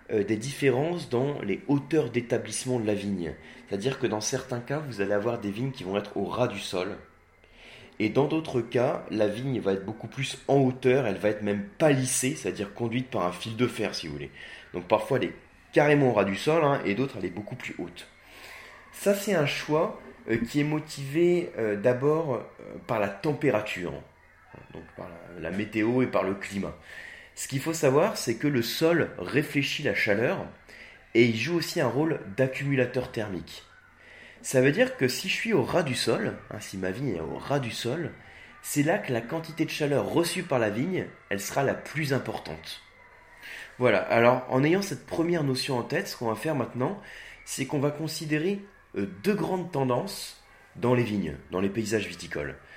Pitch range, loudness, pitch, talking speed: 105-145 Hz, -28 LUFS, 125 Hz, 195 wpm